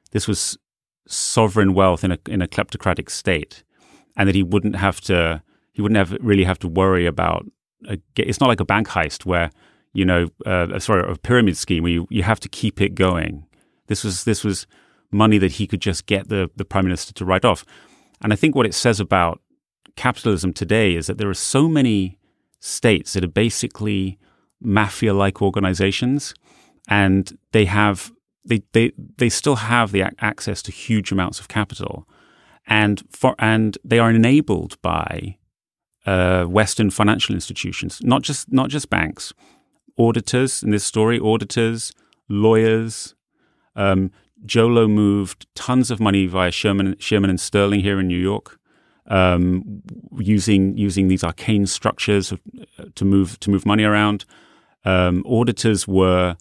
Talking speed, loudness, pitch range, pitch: 165 wpm, -19 LUFS, 95-110 Hz, 100 Hz